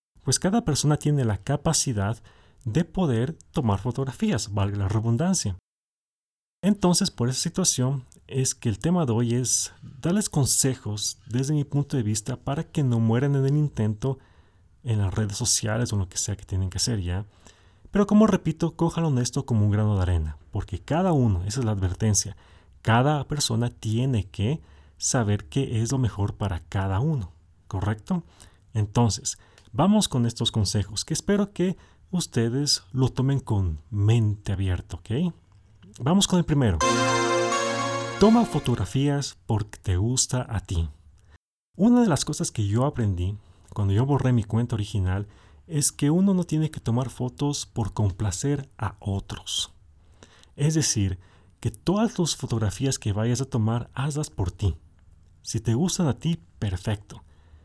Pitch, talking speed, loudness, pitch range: 115 Hz, 160 wpm, -25 LUFS, 100-140 Hz